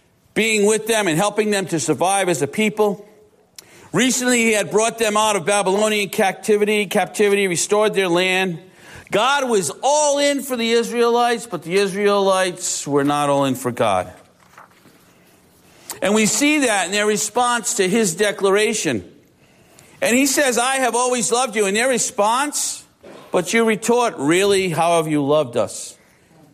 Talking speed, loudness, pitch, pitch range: 160 wpm, -18 LUFS, 210 Hz, 190-235 Hz